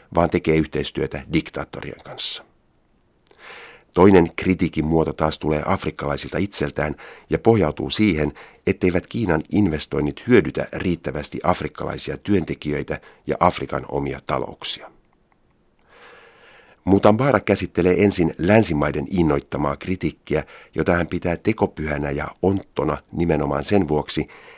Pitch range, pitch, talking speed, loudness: 75-95 Hz, 80 Hz, 100 wpm, -21 LUFS